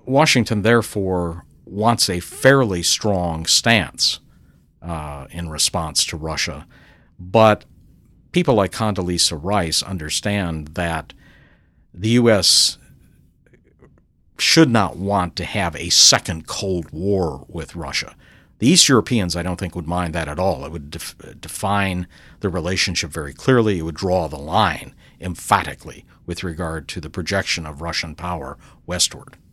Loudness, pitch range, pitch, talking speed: -18 LUFS, 85-100 Hz, 90 Hz, 135 wpm